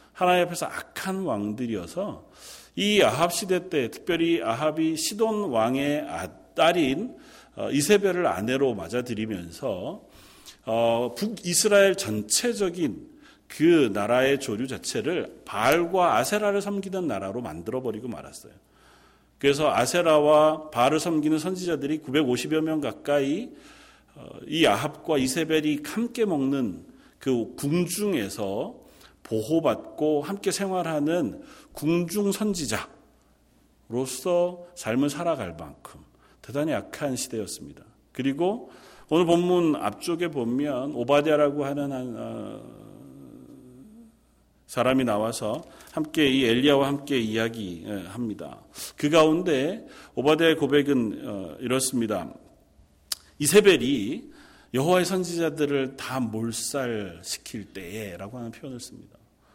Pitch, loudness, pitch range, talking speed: 150 Hz, -25 LUFS, 125-180 Hz, 245 characters per minute